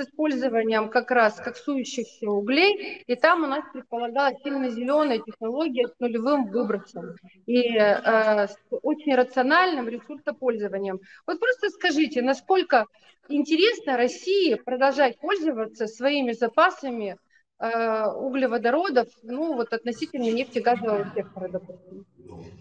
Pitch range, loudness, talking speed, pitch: 220-290 Hz, -24 LUFS, 110 wpm, 245 Hz